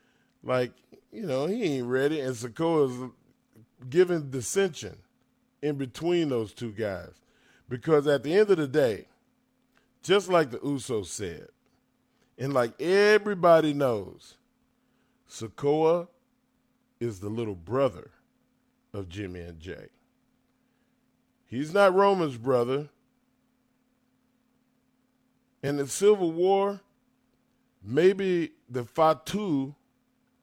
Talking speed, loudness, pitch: 105 wpm, -26 LUFS, 170 Hz